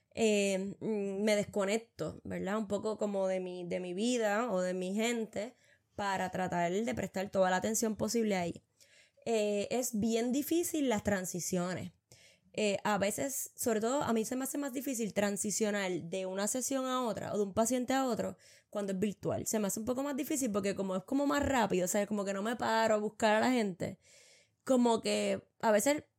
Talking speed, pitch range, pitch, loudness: 195 wpm, 195-235 Hz, 210 Hz, -33 LUFS